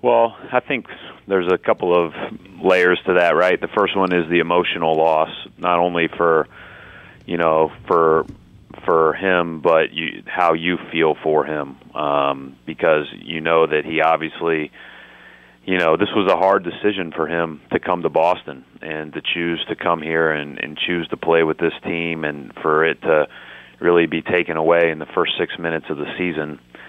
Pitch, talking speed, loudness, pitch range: 85 Hz, 185 wpm, -19 LUFS, 80-90 Hz